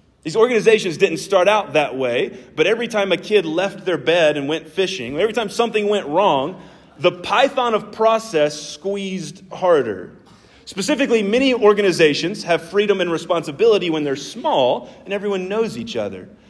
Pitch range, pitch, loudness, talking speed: 170-220 Hz, 195 Hz, -18 LUFS, 160 wpm